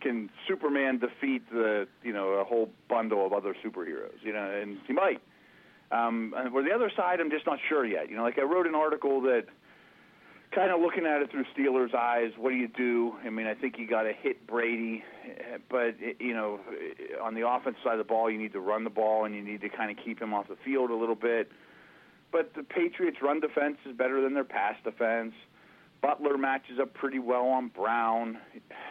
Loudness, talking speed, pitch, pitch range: -30 LUFS, 220 wpm, 120 Hz, 115-140 Hz